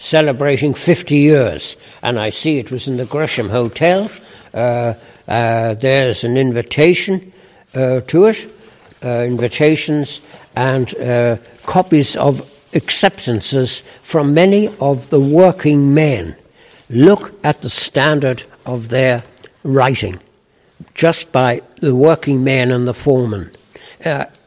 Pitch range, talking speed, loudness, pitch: 120-155 Hz, 120 wpm, -14 LUFS, 135 Hz